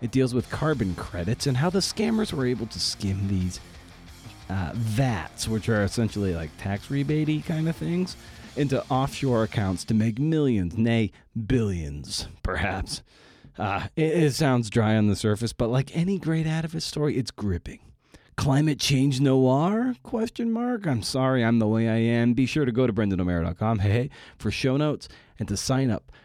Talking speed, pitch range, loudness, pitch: 180 wpm, 105-145 Hz, -25 LUFS, 120 Hz